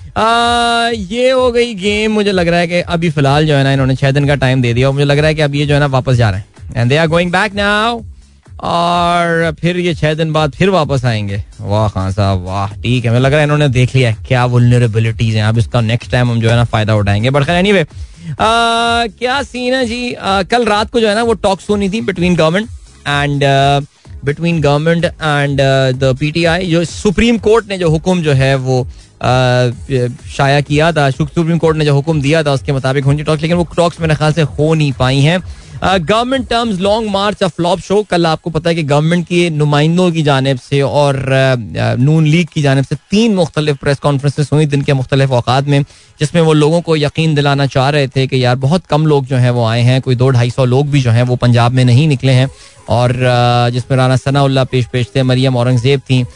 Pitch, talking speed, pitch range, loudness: 145 Hz, 160 wpm, 130-175 Hz, -12 LUFS